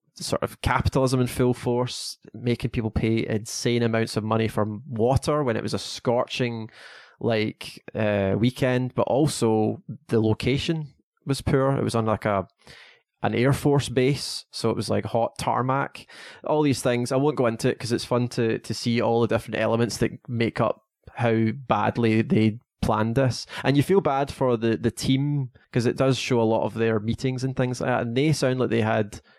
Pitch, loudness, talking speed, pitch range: 120 Hz, -24 LUFS, 200 wpm, 110-130 Hz